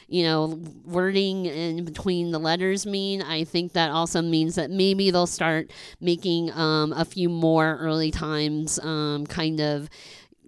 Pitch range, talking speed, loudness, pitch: 160-180 Hz, 155 wpm, -24 LUFS, 165 Hz